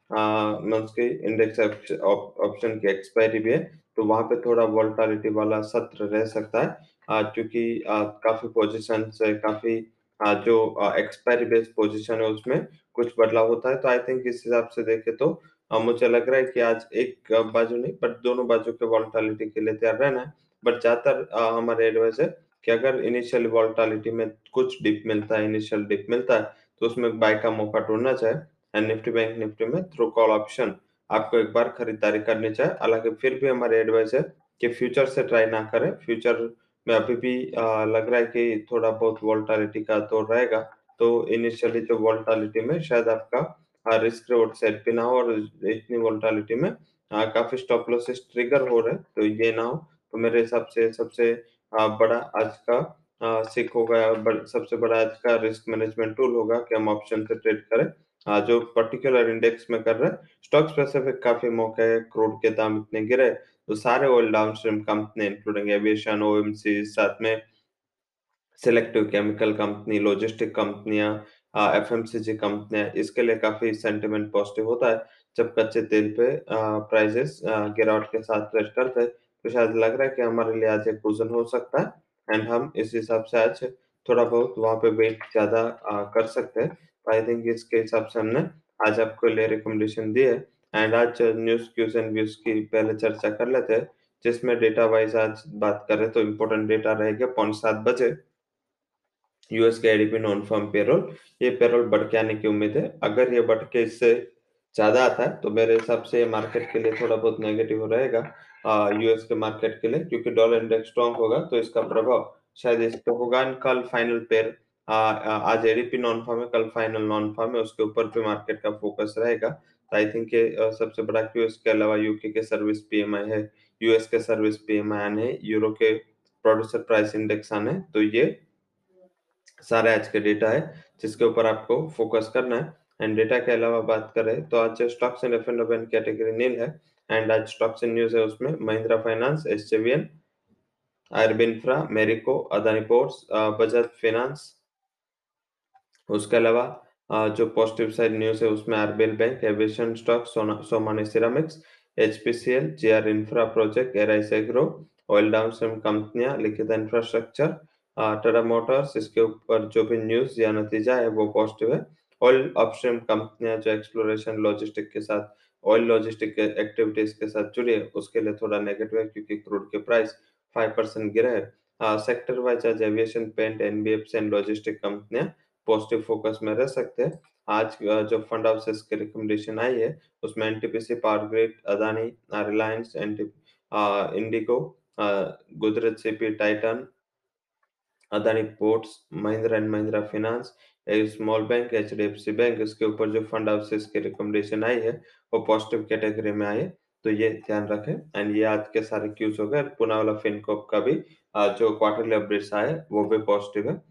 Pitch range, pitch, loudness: 110-115 Hz, 110 Hz, -24 LUFS